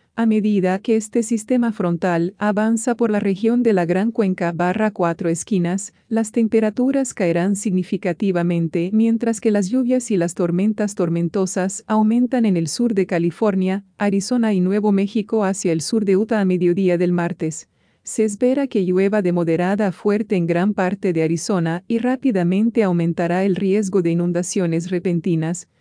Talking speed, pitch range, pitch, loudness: 160 wpm, 175-220 Hz, 195 Hz, -19 LUFS